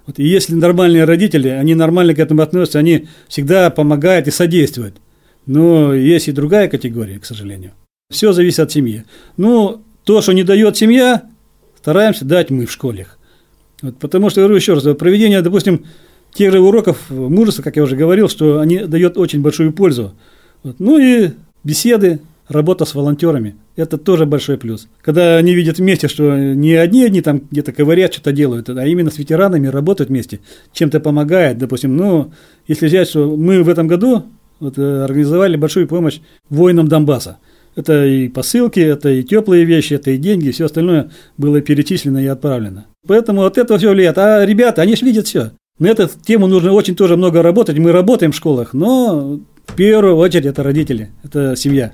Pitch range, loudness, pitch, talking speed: 145-185 Hz, -12 LUFS, 160 Hz, 175 wpm